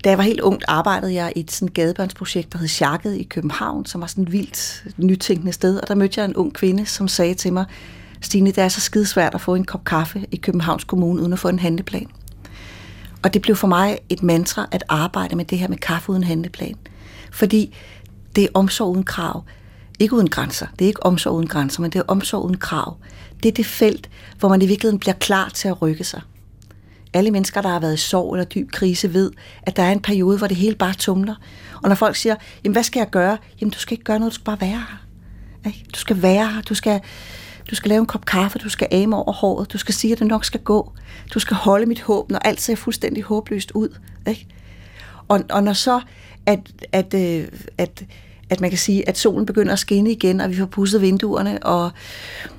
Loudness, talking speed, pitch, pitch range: -19 LUFS, 235 wpm, 190 Hz, 165-205 Hz